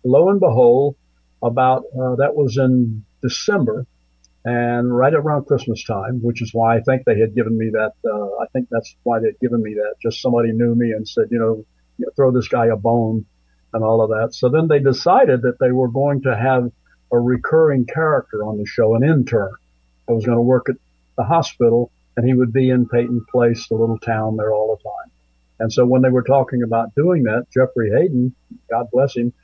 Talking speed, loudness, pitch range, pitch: 215 wpm, -18 LUFS, 110-130 Hz, 120 Hz